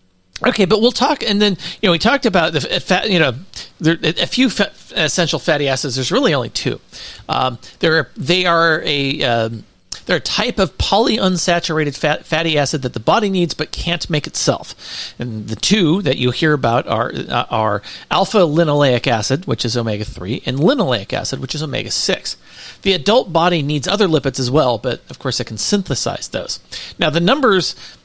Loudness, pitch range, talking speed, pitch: -16 LUFS, 130-180 Hz, 195 wpm, 155 Hz